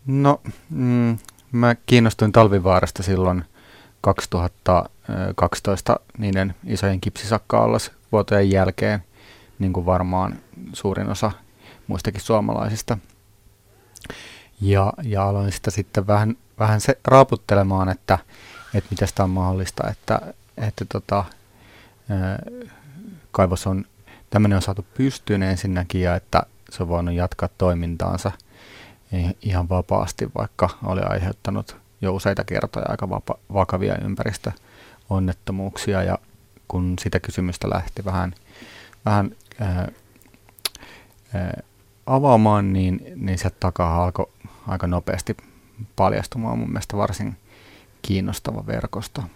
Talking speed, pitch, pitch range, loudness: 105 wpm, 100 Hz, 95-110 Hz, -22 LUFS